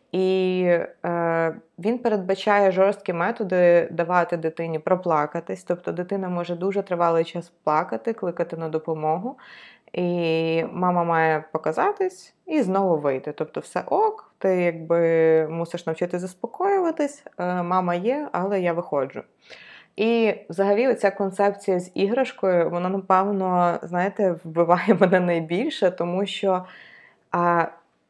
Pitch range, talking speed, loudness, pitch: 170-200 Hz, 115 wpm, -23 LUFS, 180 Hz